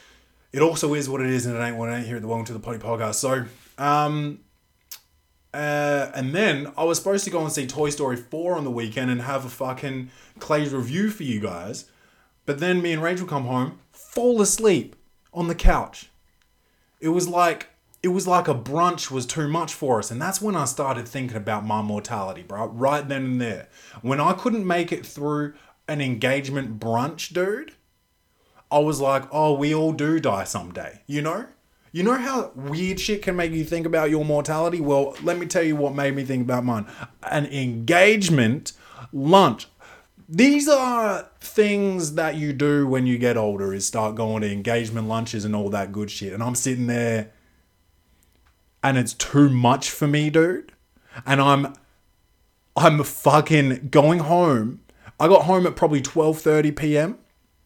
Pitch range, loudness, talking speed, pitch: 120-165 Hz, -22 LUFS, 185 wpm, 140 Hz